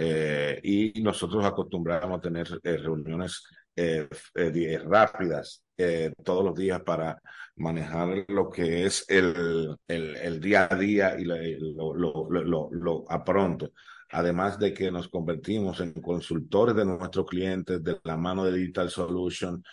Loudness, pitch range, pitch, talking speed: -28 LUFS, 80-95 Hz, 90 Hz, 150 wpm